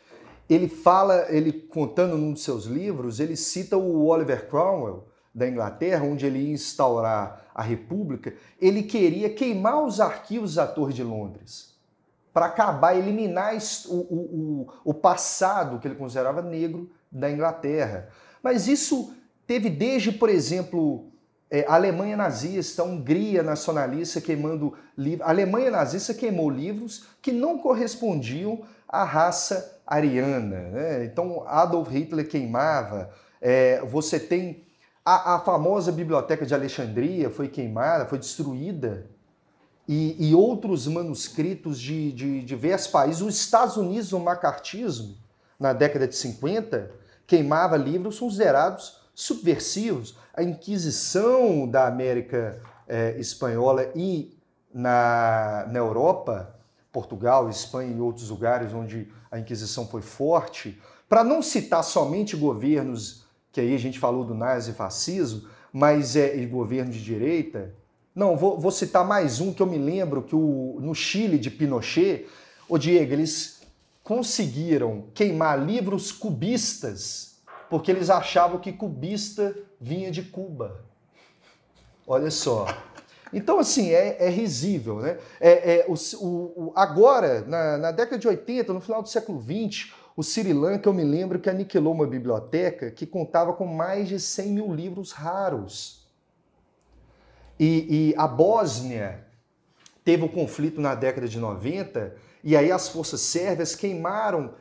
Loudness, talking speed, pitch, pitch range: -24 LUFS, 135 wpm, 160 Hz, 135-190 Hz